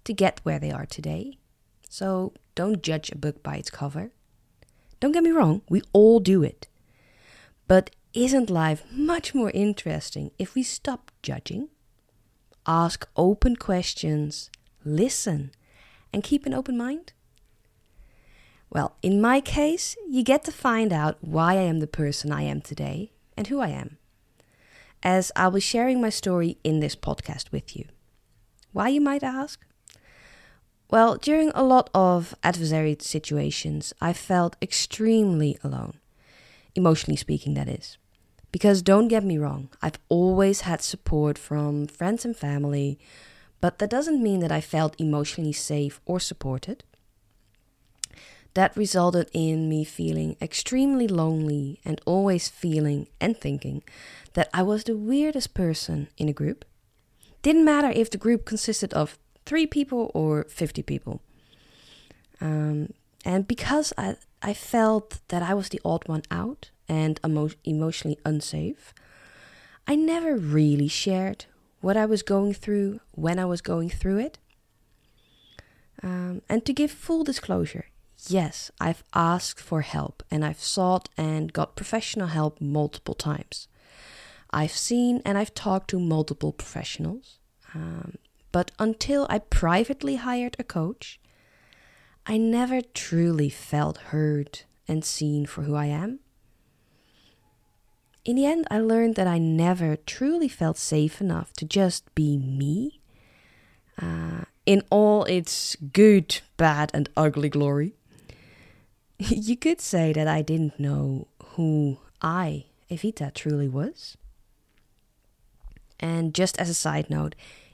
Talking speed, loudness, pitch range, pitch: 140 wpm, -25 LUFS, 145-215 Hz, 165 Hz